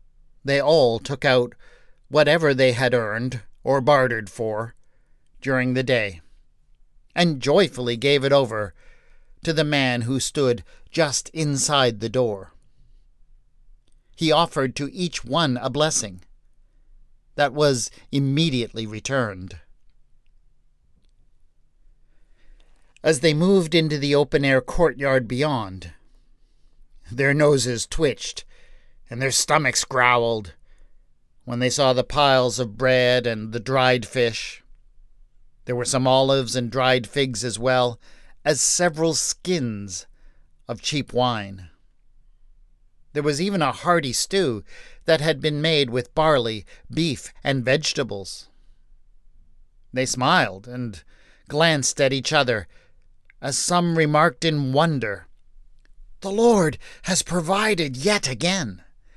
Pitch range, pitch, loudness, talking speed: 115-150 Hz, 130 Hz, -21 LUFS, 115 wpm